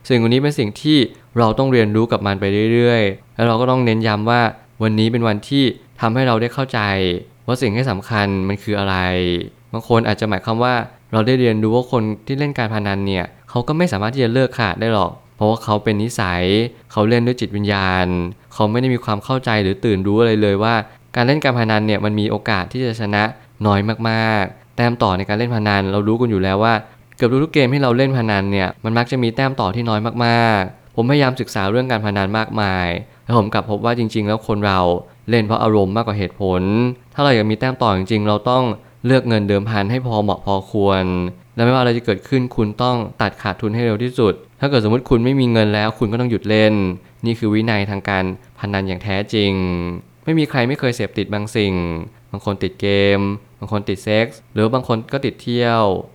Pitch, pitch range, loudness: 110 Hz, 100-120 Hz, -18 LUFS